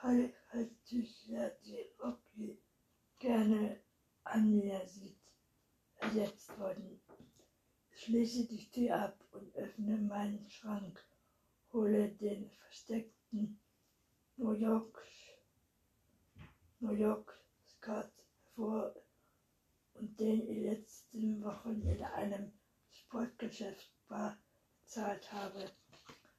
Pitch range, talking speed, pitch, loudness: 205-230 Hz, 85 wpm, 215 Hz, -40 LUFS